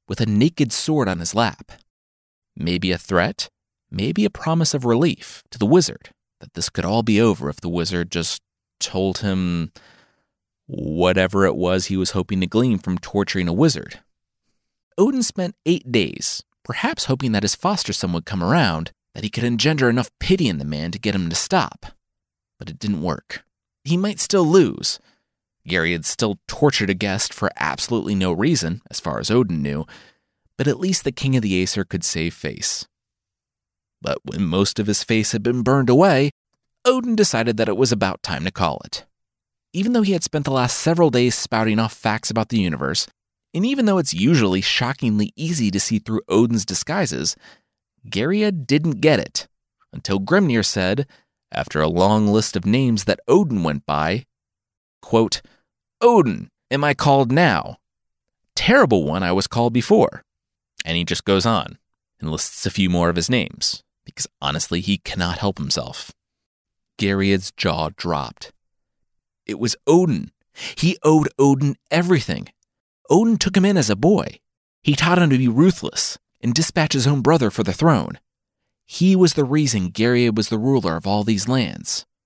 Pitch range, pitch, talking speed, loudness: 95-145 Hz, 110 Hz, 175 wpm, -19 LUFS